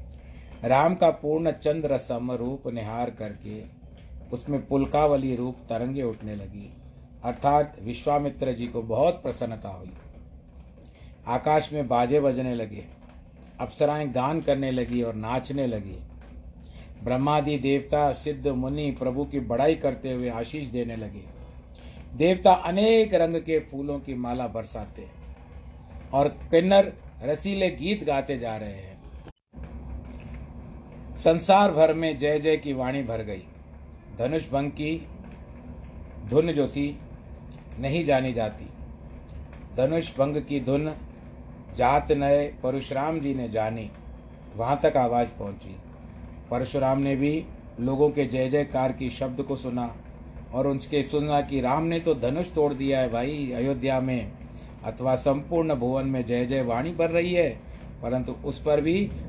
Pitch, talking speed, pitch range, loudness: 125 Hz, 135 wpm, 100-145 Hz, -26 LUFS